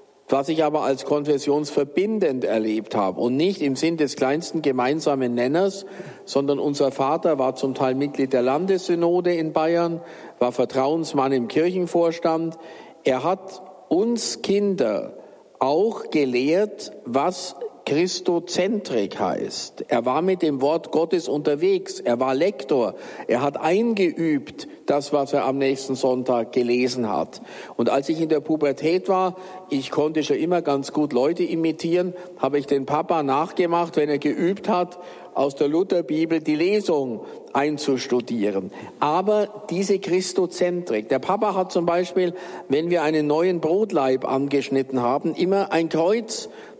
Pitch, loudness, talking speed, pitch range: 160 Hz, -22 LUFS, 140 wpm, 140-180 Hz